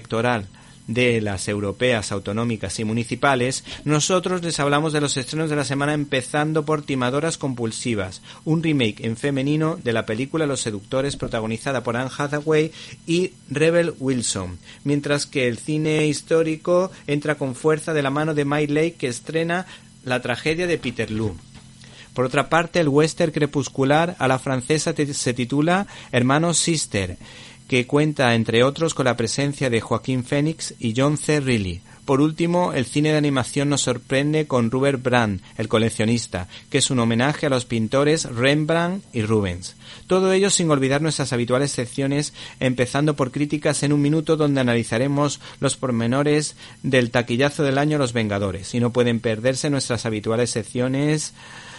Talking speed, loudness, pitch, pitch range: 160 wpm, -21 LUFS, 135 Hz, 120-150 Hz